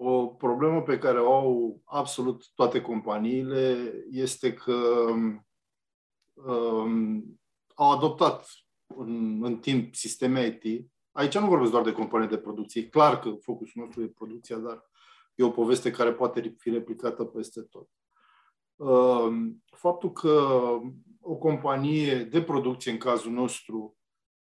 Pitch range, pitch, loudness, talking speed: 115-135 Hz, 120 Hz, -27 LUFS, 130 wpm